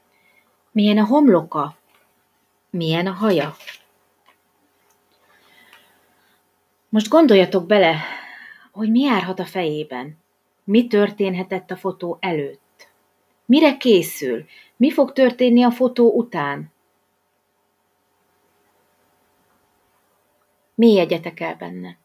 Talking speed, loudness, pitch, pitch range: 85 wpm, -18 LUFS, 195 Hz, 170-235 Hz